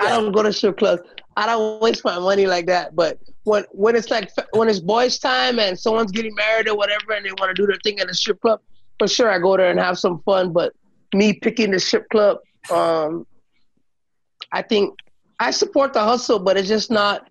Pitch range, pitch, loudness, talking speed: 190-225 Hz, 210 Hz, -19 LUFS, 225 wpm